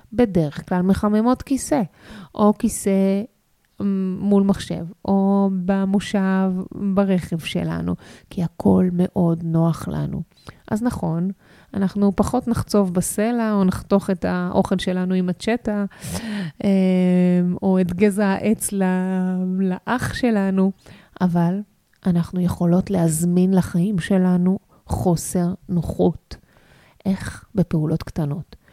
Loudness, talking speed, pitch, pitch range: -21 LUFS, 100 wpm, 190 Hz, 180-200 Hz